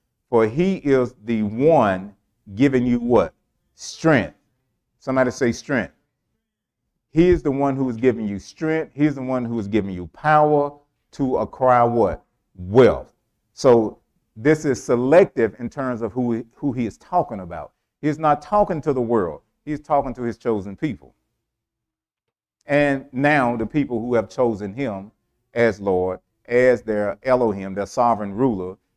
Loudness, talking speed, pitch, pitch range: -20 LUFS, 150 wpm, 120 Hz, 110-140 Hz